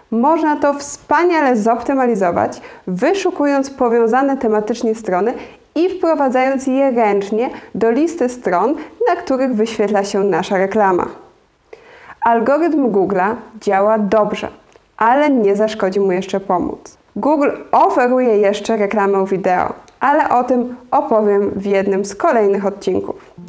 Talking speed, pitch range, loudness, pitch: 115 wpm, 200-275 Hz, -16 LUFS, 230 Hz